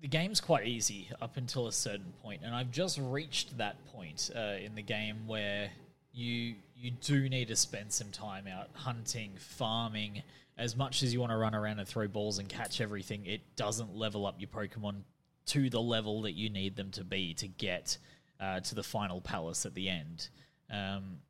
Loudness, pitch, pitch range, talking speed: -36 LUFS, 110 Hz, 100-130 Hz, 200 wpm